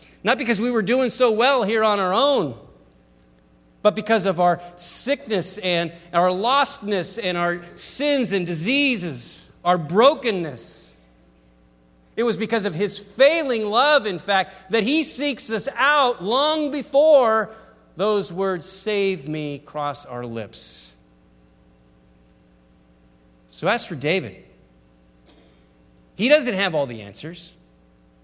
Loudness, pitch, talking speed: -21 LUFS, 180 Hz, 125 wpm